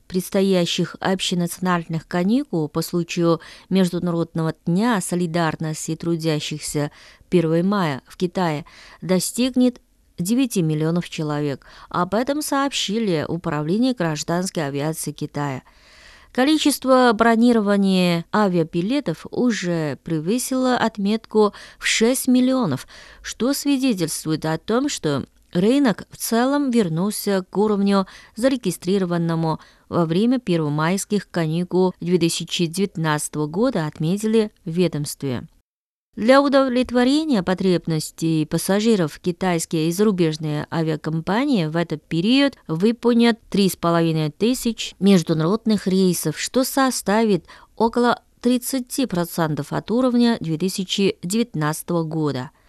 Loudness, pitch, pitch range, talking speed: -21 LUFS, 185 Hz, 165-230 Hz, 90 wpm